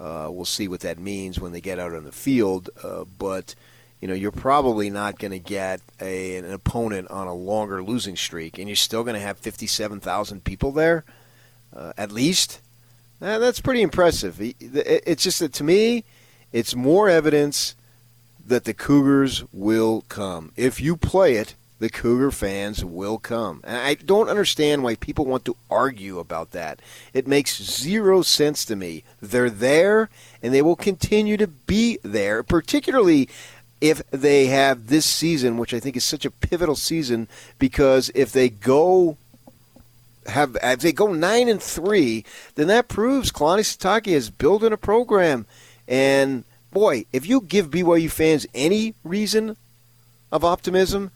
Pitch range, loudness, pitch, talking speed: 110-165 Hz, -21 LUFS, 125 Hz, 165 wpm